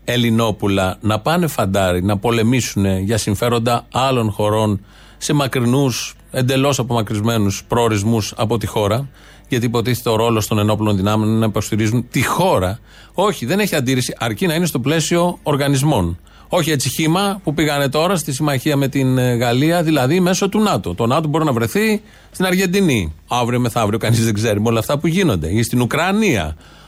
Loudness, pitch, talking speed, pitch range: -17 LUFS, 120 Hz, 165 wpm, 110-150 Hz